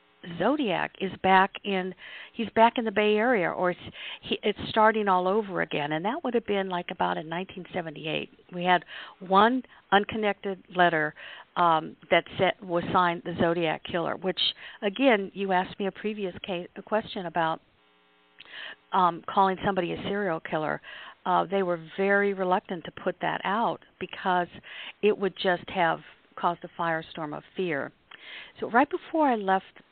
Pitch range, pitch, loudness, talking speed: 175-205 Hz, 185 Hz, -27 LUFS, 160 wpm